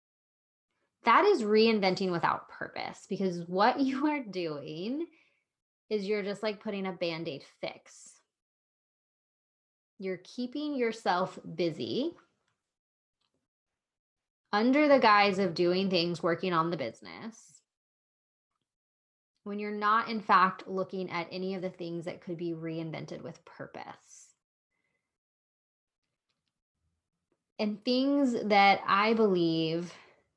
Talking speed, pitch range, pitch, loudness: 110 wpm, 165-215 Hz, 185 Hz, -29 LUFS